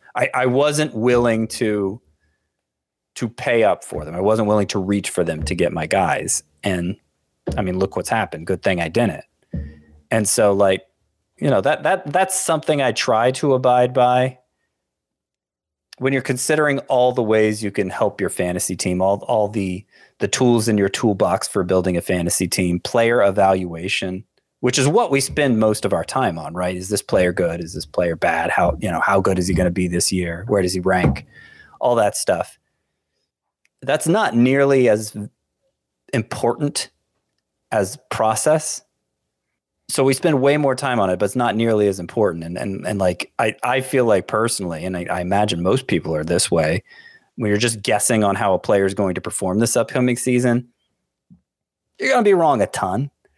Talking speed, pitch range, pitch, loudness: 190 wpm, 90-125 Hz, 105 Hz, -19 LUFS